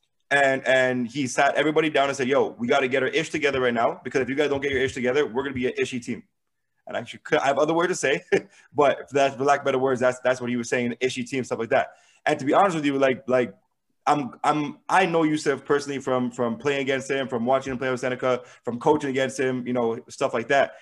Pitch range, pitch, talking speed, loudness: 125-140 Hz, 135 Hz, 270 wpm, -24 LUFS